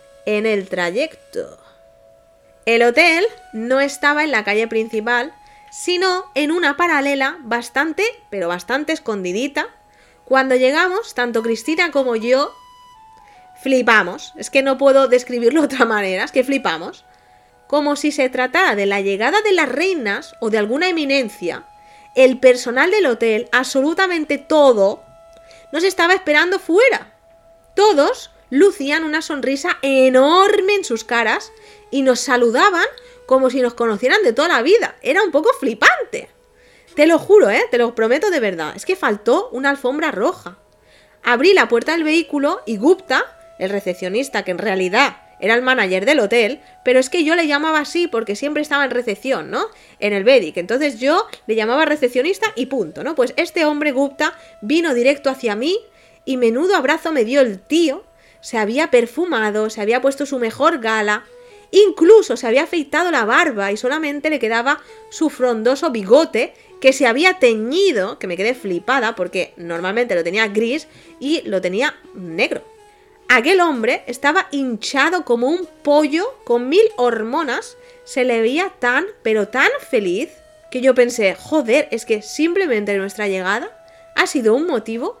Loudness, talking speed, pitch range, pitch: -17 LUFS, 160 wpm, 235-345 Hz, 275 Hz